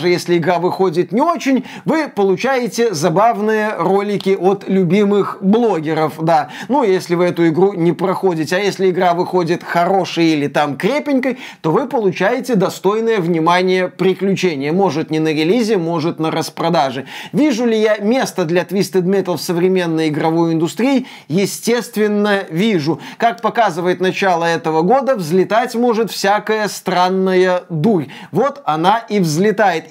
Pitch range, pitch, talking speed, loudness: 170-215 Hz, 185 Hz, 140 wpm, -16 LUFS